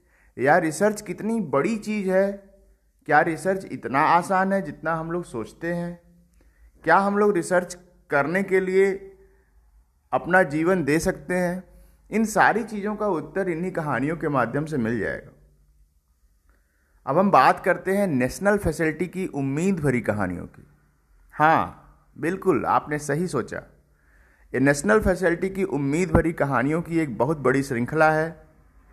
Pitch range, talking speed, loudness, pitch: 125-190 Hz, 145 wpm, -23 LUFS, 165 Hz